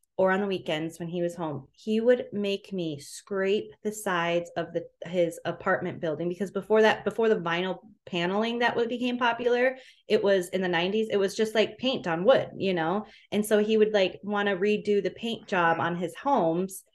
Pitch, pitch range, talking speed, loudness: 195 Hz, 175-215 Hz, 210 wpm, -27 LUFS